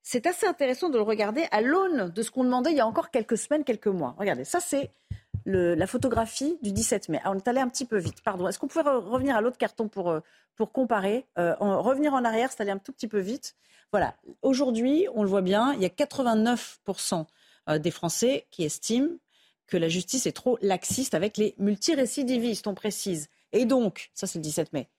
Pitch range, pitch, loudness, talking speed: 195-265 Hz, 230 Hz, -27 LUFS, 220 wpm